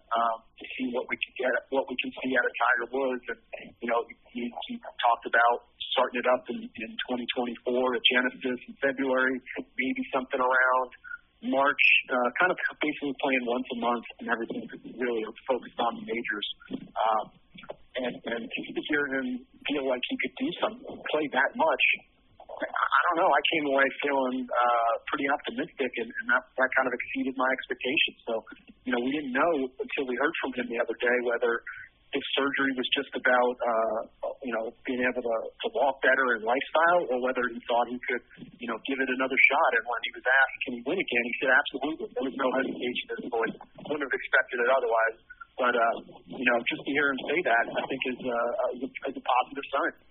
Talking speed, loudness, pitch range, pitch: 205 wpm, -27 LUFS, 125-150 Hz, 130 Hz